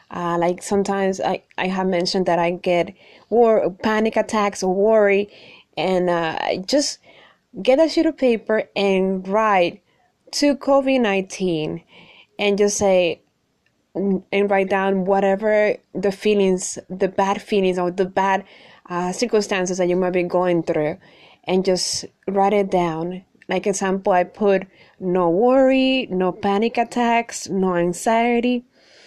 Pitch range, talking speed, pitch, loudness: 180-215 Hz, 140 wpm, 195 Hz, -20 LUFS